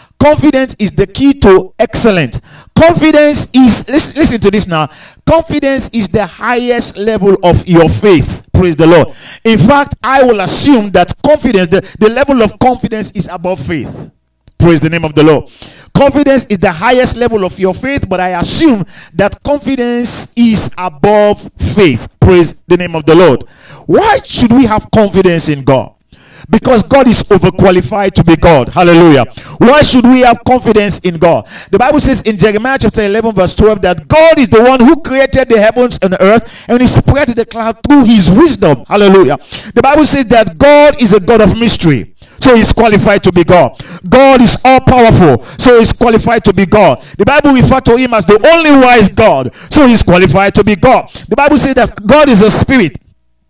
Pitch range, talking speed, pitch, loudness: 180-255 Hz, 190 wpm, 215 Hz, -7 LUFS